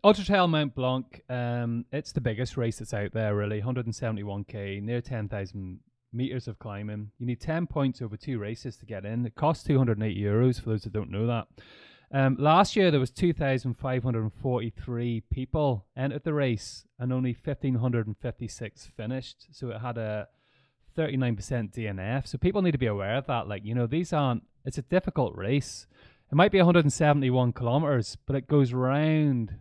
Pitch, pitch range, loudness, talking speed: 125 Hz, 110-140 Hz, -28 LUFS, 205 wpm